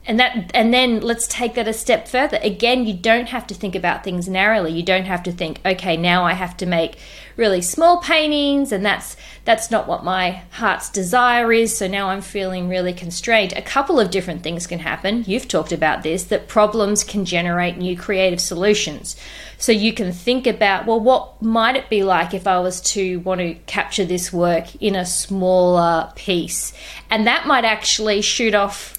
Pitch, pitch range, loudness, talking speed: 200 Hz, 180-225 Hz, -18 LUFS, 200 wpm